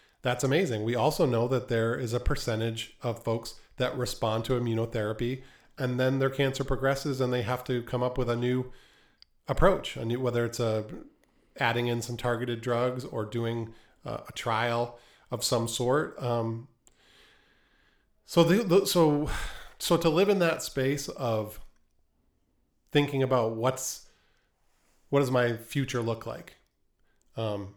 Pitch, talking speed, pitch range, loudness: 120 Hz, 155 wpm, 115-130 Hz, -29 LUFS